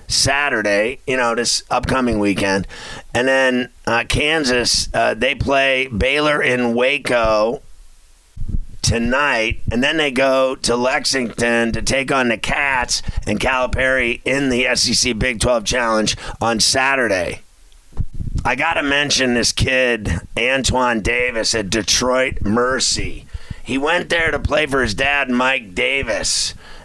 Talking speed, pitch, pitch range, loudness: 130 wpm, 120 Hz, 110-130 Hz, -17 LUFS